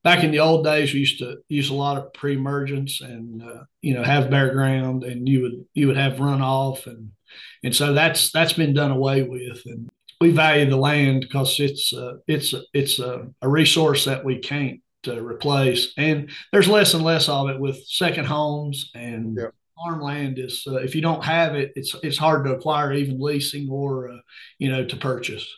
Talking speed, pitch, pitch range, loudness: 200 wpm, 140 Hz, 130-150 Hz, -21 LUFS